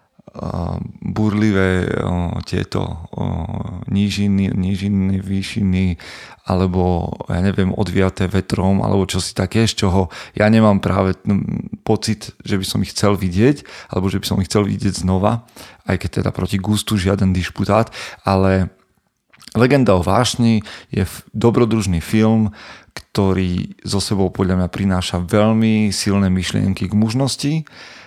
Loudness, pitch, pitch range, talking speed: -18 LUFS, 100 Hz, 95-110 Hz, 135 wpm